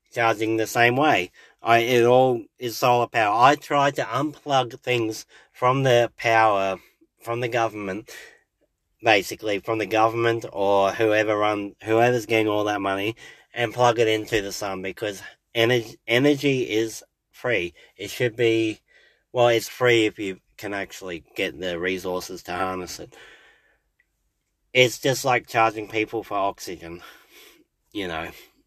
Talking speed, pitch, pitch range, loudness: 145 wpm, 115 Hz, 105-125 Hz, -22 LUFS